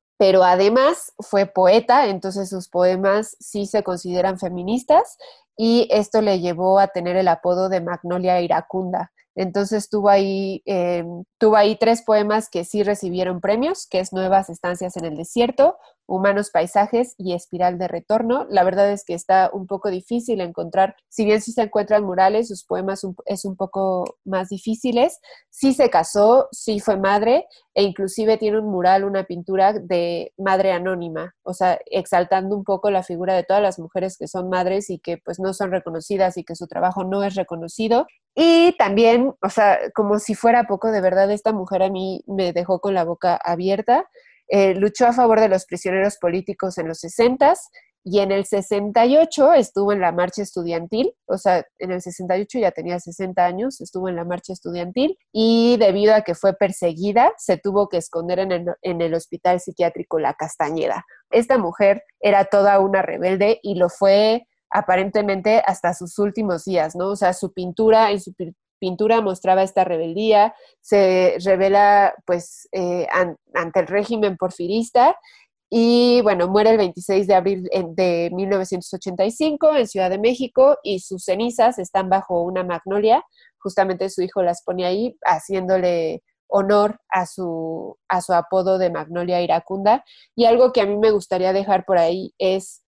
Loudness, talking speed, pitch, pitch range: -19 LUFS, 170 wpm, 195 Hz, 180-215 Hz